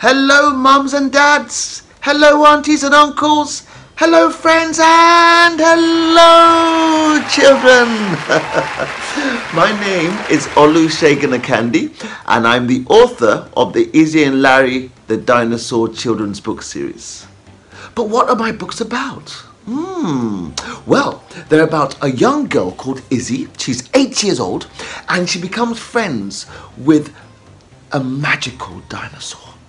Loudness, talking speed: -12 LUFS, 120 wpm